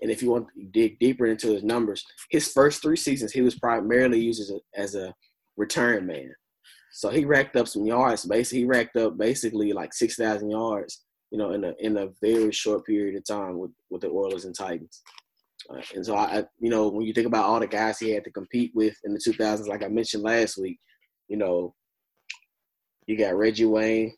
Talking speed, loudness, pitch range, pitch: 215 wpm, -25 LUFS, 105-120 Hz, 110 Hz